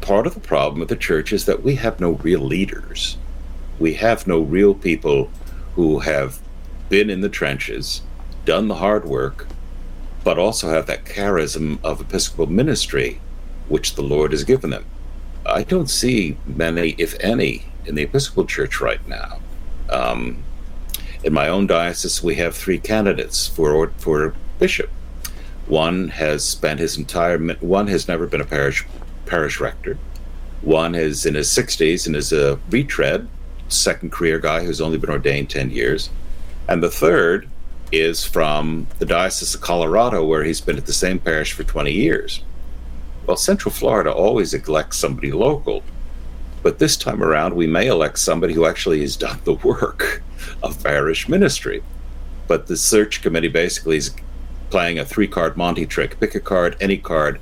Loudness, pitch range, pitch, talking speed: -19 LUFS, 60-80 Hz, 65 Hz, 165 wpm